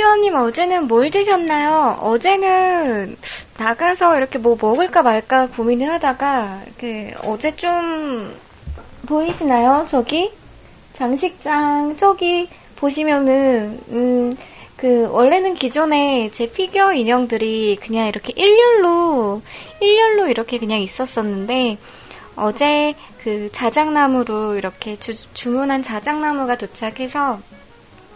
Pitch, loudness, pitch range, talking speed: 260 Hz, -17 LUFS, 230-320 Hz, 240 characters per minute